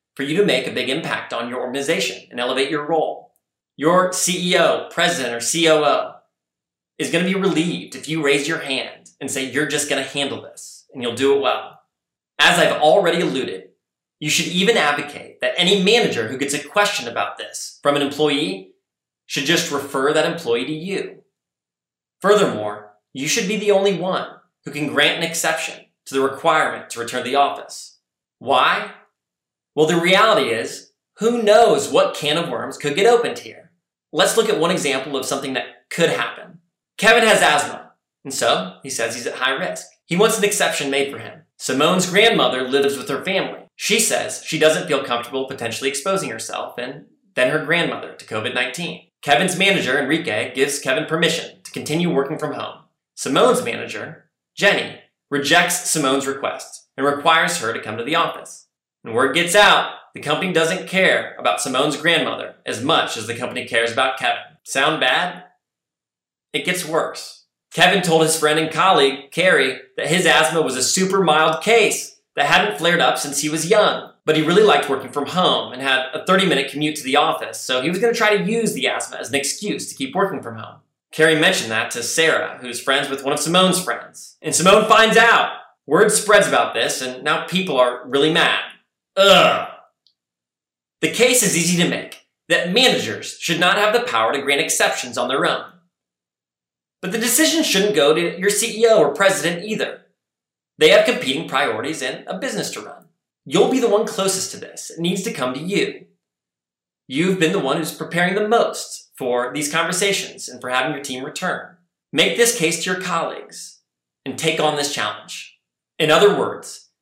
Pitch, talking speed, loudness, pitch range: 160 Hz, 190 wpm, -18 LUFS, 135-190 Hz